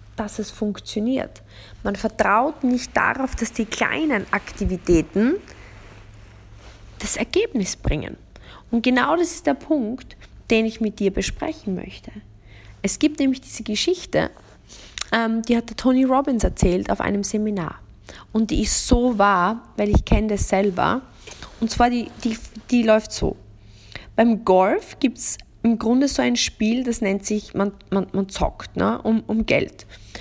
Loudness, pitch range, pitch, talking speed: -21 LUFS, 185-245 Hz, 220 Hz, 155 wpm